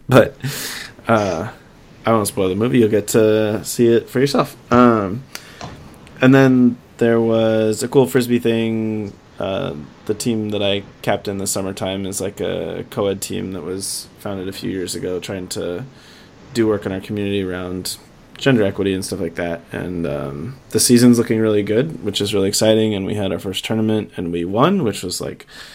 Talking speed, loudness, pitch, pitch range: 190 wpm, -18 LUFS, 105 Hz, 95-115 Hz